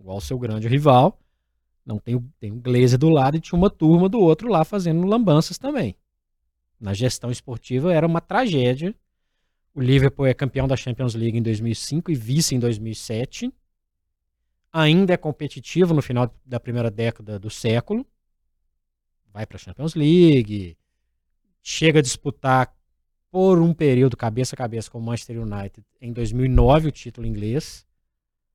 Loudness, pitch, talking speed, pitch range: -21 LUFS, 125 Hz, 155 wpm, 110-155 Hz